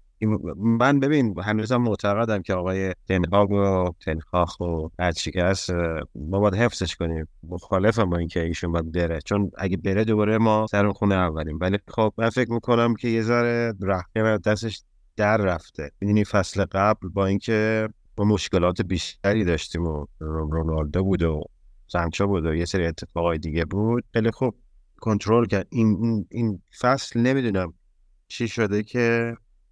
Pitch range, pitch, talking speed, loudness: 85-110 Hz, 100 Hz, 150 wpm, -24 LUFS